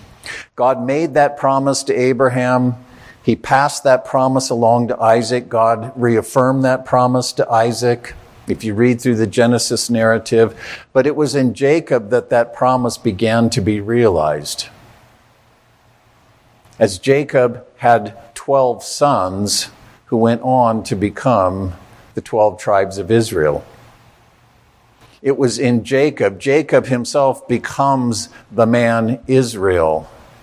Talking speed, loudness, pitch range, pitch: 125 wpm, -16 LUFS, 115-130 Hz, 120 Hz